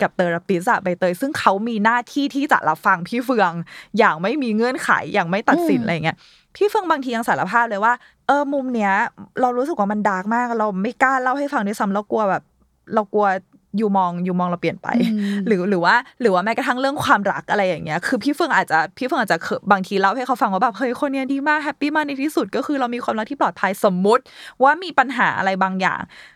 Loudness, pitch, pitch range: -19 LUFS, 230 Hz, 195-270 Hz